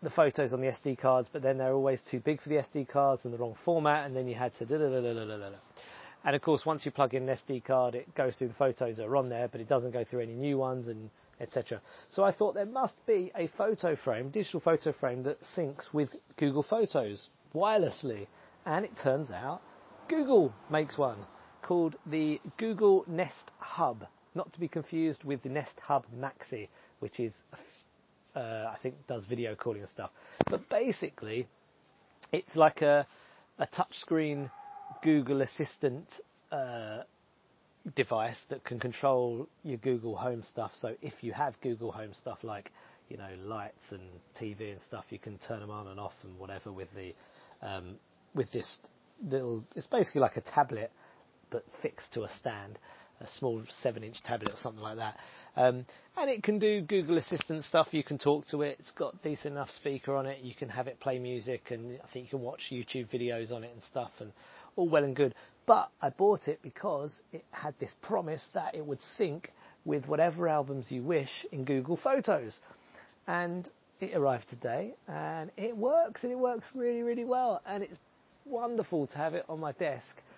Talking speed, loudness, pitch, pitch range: 190 wpm, -33 LUFS, 140 Hz, 125-165 Hz